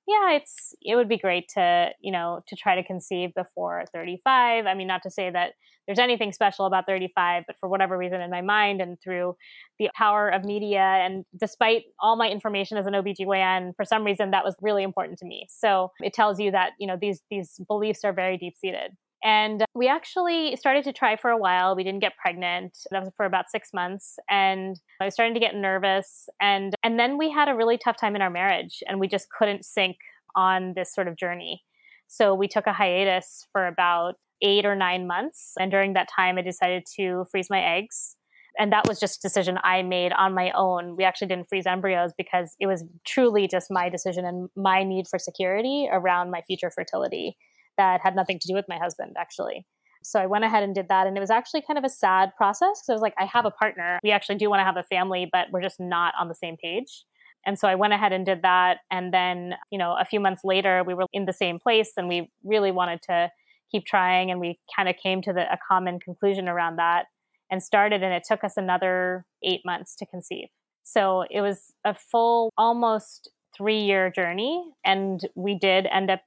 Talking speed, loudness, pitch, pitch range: 225 wpm, -24 LUFS, 190 Hz, 180-210 Hz